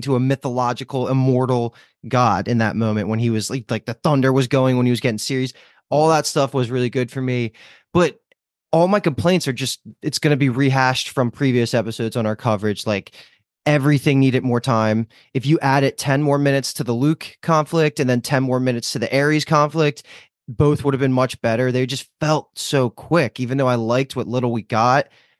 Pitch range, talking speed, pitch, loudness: 120-140 Hz, 215 wpm, 130 Hz, -19 LUFS